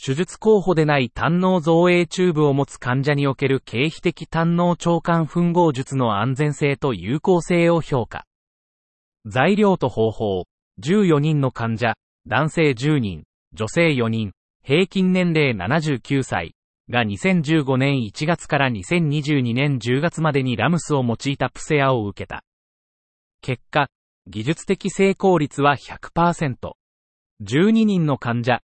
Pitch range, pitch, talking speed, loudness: 120-170 Hz, 145 Hz, 215 characters per minute, -20 LUFS